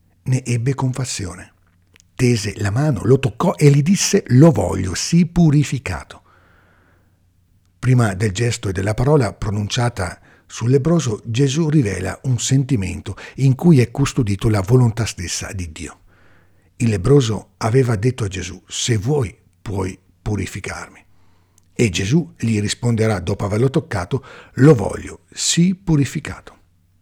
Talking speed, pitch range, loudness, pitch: 125 wpm, 90-135 Hz, -18 LUFS, 110 Hz